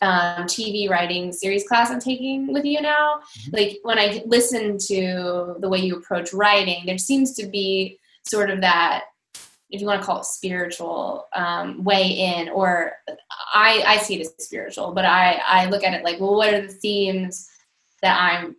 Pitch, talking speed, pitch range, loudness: 195 Hz, 185 wpm, 180-215 Hz, -20 LUFS